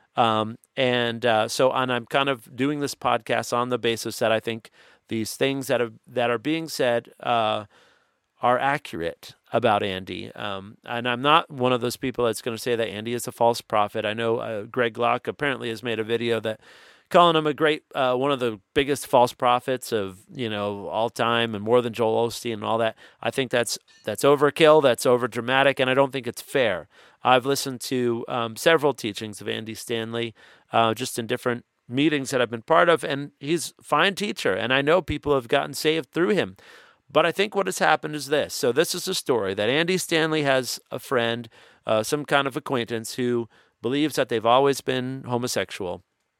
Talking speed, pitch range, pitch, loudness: 210 wpm, 115-140 Hz, 125 Hz, -24 LUFS